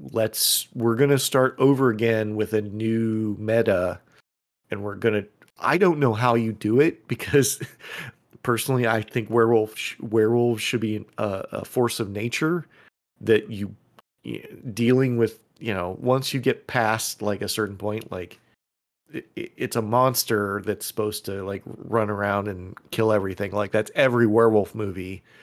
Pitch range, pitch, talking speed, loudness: 105-120 Hz, 110 Hz, 155 wpm, -23 LUFS